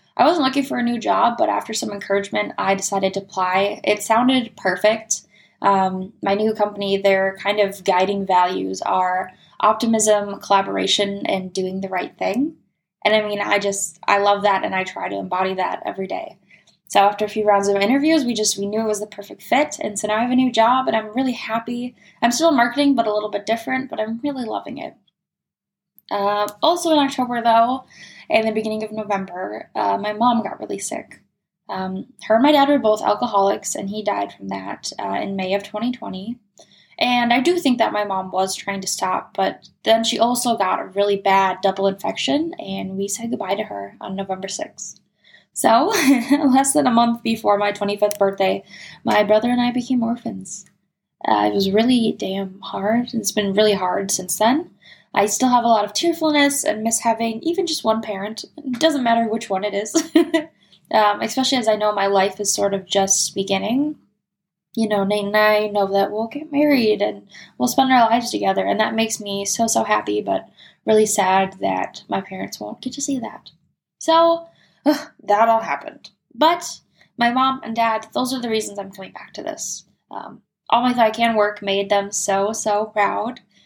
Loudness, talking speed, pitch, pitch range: -19 LUFS, 200 wpm, 210 Hz, 195-240 Hz